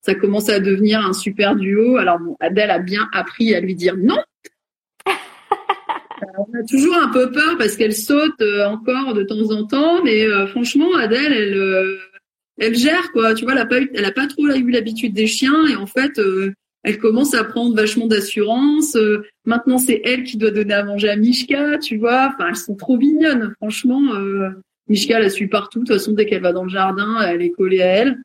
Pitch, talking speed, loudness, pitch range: 225 Hz, 225 wpm, -17 LUFS, 205-265 Hz